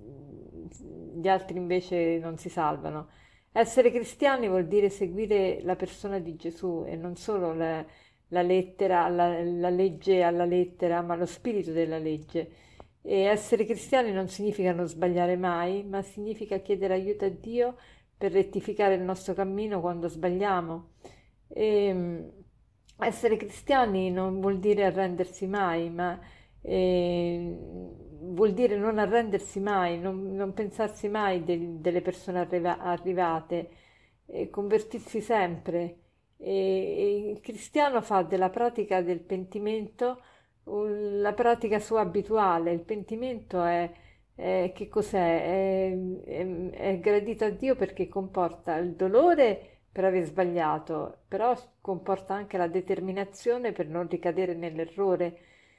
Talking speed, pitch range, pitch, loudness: 130 wpm, 175-210 Hz, 190 Hz, -28 LUFS